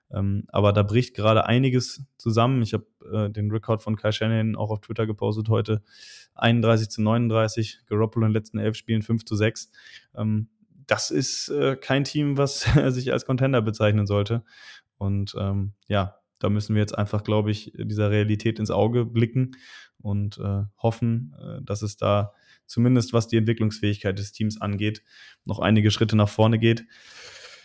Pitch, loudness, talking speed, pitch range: 110 Hz, -24 LUFS, 175 wpm, 105-115 Hz